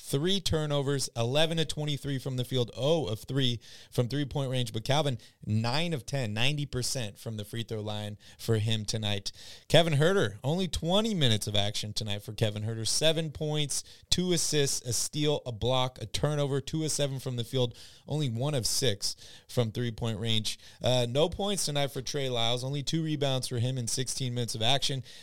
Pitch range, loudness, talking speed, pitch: 115-145 Hz, -30 LUFS, 190 wpm, 125 Hz